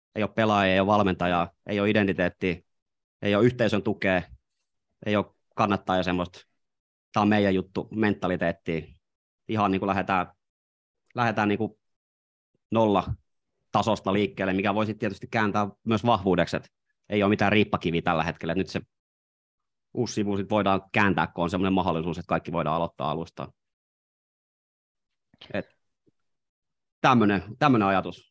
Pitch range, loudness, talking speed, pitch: 90-105 Hz, -26 LUFS, 135 wpm, 100 Hz